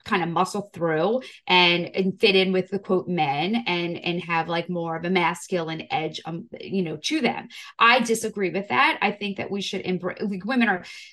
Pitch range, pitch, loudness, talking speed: 175-205 Hz, 185 Hz, -23 LUFS, 210 wpm